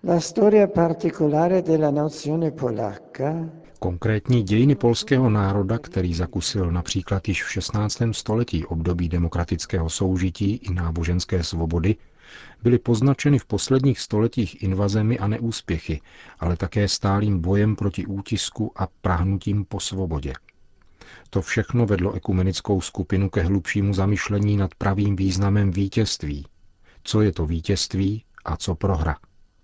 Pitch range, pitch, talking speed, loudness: 95-115 Hz, 100 Hz, 110 wpm, -23 LUFS